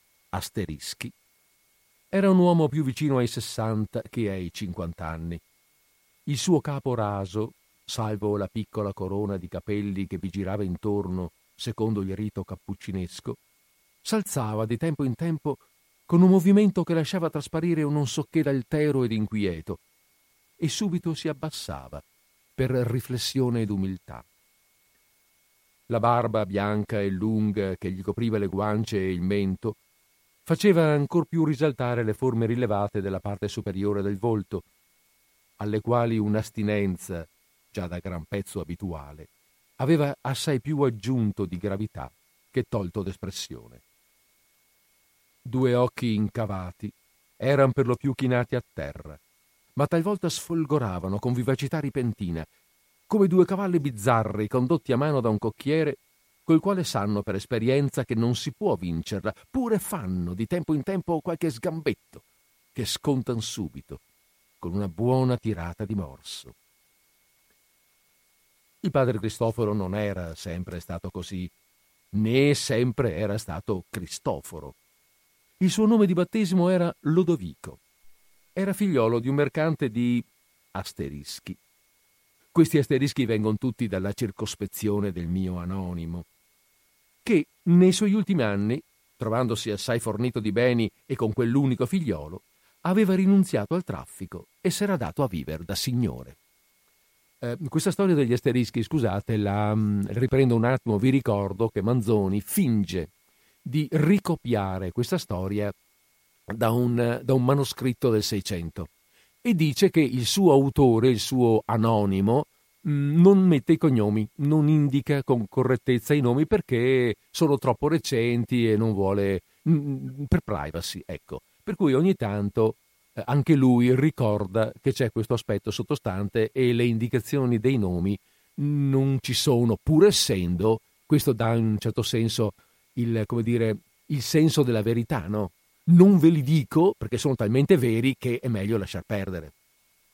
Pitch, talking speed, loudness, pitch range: 115 Hz, 135 wpm, -25 LUFS, 100-145 Hz